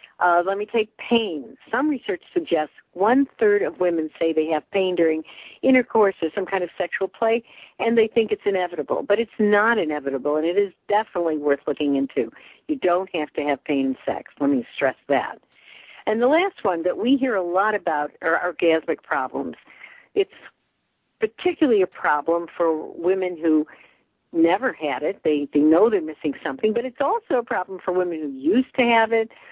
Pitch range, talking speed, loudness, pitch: 160-235 Hz, 200 wpm, -22 LUFS, 190 Hz